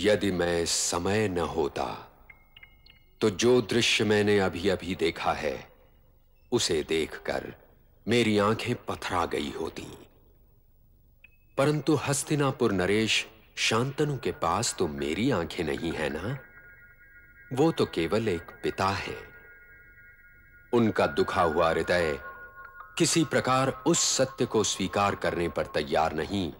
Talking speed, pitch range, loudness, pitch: 115 wpm, 100-160 Hz, -27 LUFS, 130 Hz